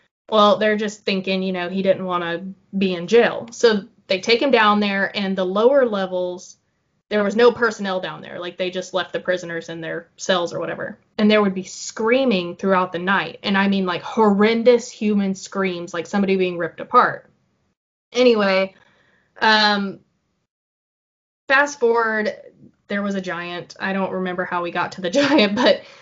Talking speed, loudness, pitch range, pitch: 180 wpm, -19 LUFS, 180-215 Hz, 195 Hz